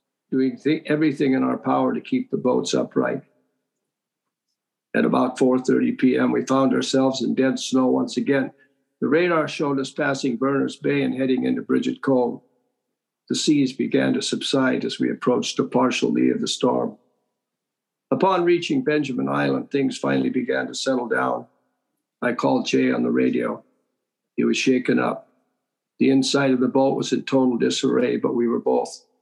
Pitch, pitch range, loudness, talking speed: 130 Hz, 90-140 Hz, -22 LUFS, 170 wpm